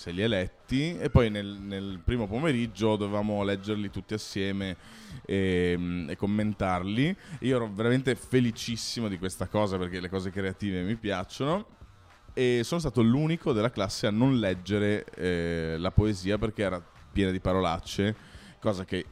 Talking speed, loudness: 155 wpm, -29 LUFS